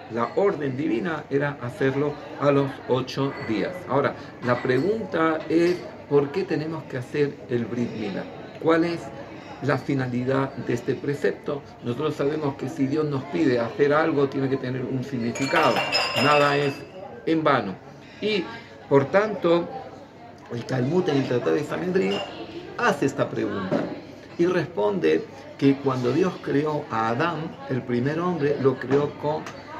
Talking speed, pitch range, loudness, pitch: 145 wpm, 130-155 Hz, -24 LUFS, 140 Hz